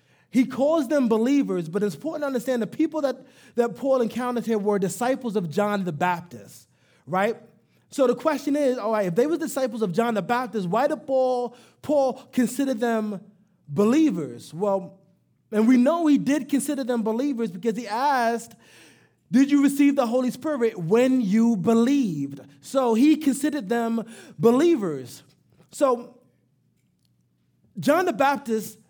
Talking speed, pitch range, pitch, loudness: 155 wpm, 205-270 Hz, 235 Hz, -23 LUFS